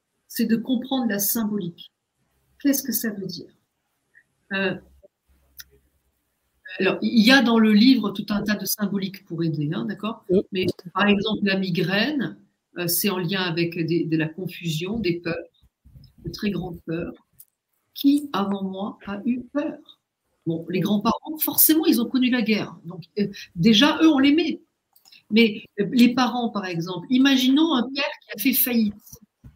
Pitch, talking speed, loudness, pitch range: 205 Hz, 165 wpm, -22 LUFS, 180-245 Hz